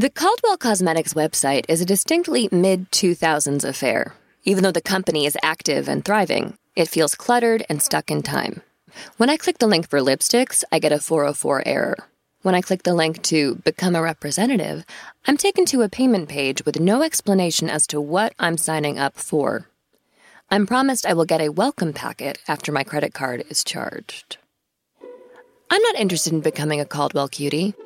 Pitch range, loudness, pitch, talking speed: 155-230 Hz, -20 LUFS, 175 Hz, 180 wpm